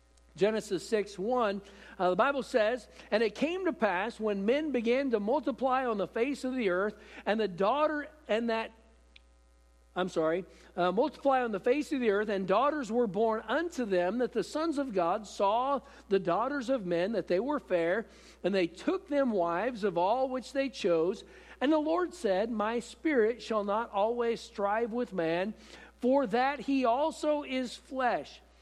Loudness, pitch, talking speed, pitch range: -31 LUFS, 230 Hz, 180 wpm, 195-265 Hz